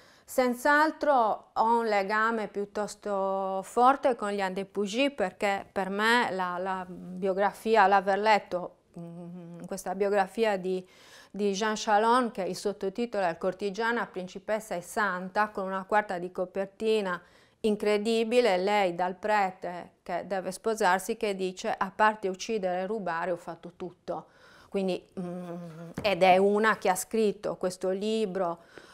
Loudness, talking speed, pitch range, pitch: -28 LUFS, 135 wpm, 185-215 Hz, 195 Hz